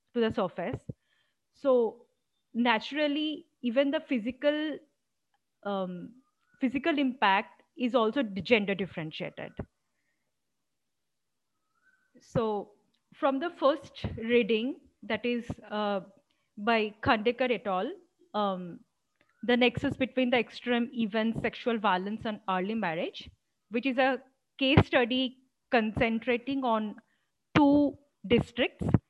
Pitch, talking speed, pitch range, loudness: 245 Hz, 100 wpm, 220-280 Hz, -29 LUFS